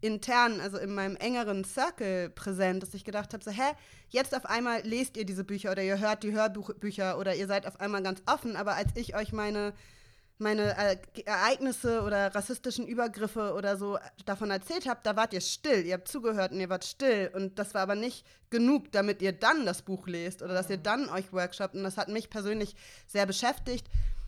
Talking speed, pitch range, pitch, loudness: 205 wpm, 190-225 Hz, 205 Hz, -32 LUFS